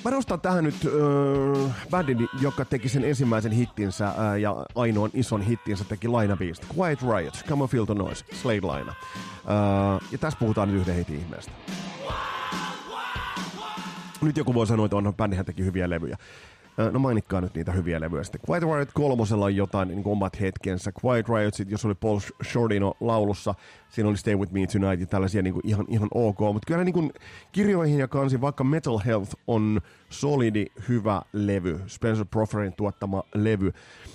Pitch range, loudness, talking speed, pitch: 100-130 Hz, -26 LUFS, 170 wpm, 105 Hz